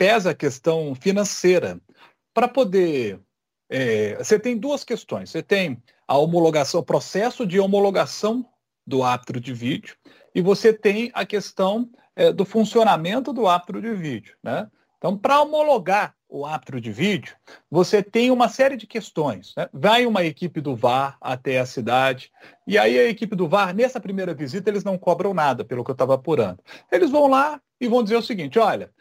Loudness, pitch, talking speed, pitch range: -21 LUFS, 195 Hz, 175 wpm, 155-230 Hz